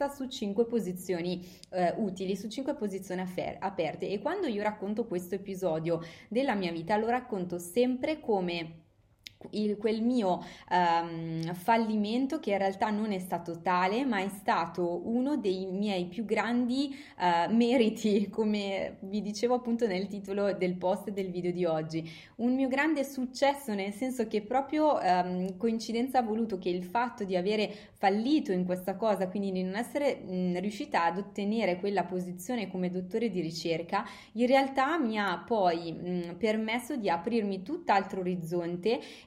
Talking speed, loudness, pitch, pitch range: 155 wpm, -31 LUFS, 200 Hz, 180-235 Hz